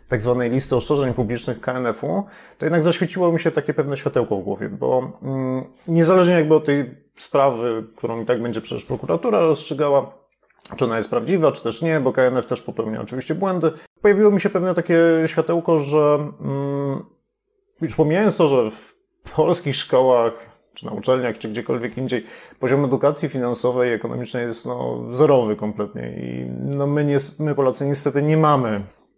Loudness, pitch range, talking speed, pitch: -20 LUFS, 120-160 Hz, 170 wpm, 140 Hz